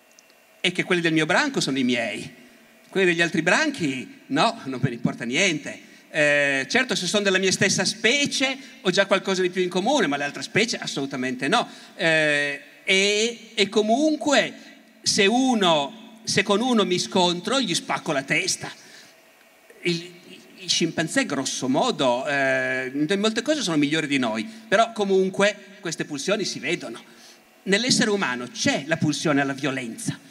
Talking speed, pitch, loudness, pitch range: 160 wpm, 190 Hz, -22 LUFS, 160-220 Hz